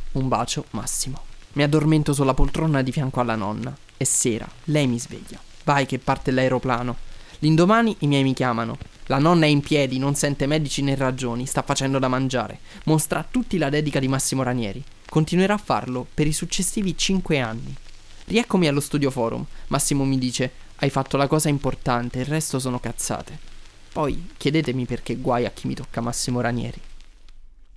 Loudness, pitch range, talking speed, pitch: -22 LUFS, 120-150 Hz, 175 wpm, 135 Hz